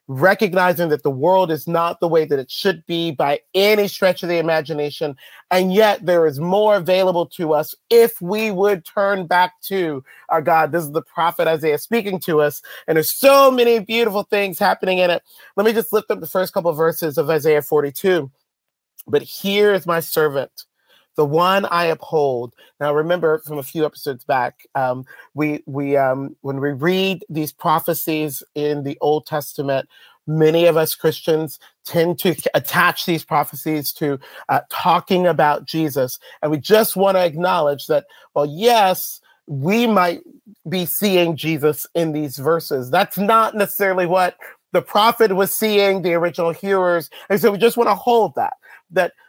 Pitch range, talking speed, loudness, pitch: 150-195 Hz, 175 wpm, -18 LUFS, 170 Hz